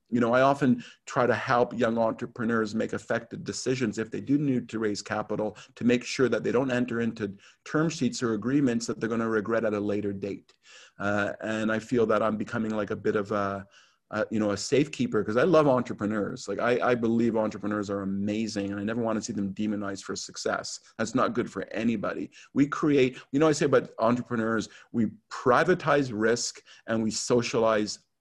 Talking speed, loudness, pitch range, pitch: 205 wpm, -27 LUFS, 105-120 Hz, 110 Hz